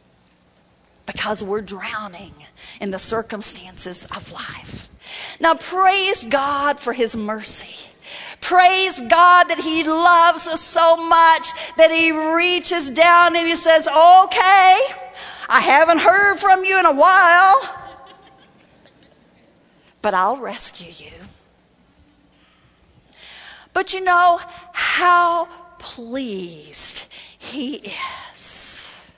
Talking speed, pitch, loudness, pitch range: 100 wpm, 330 Hz, -15 LUFS, 250-355 Hz